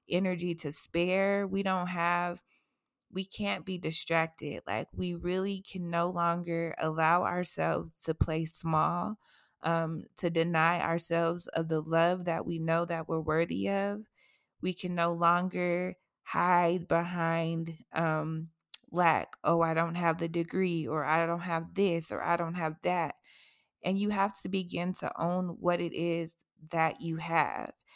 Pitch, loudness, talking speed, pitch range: 170 Hz, -31 LUFS, 155 wpm, 165-180 Hz